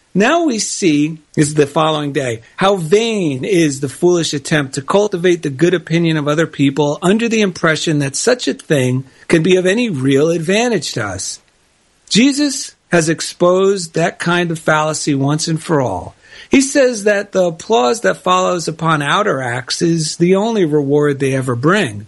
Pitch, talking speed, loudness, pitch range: 165 Hz, 175 wpm, -15 LUFS, 145-190 Hz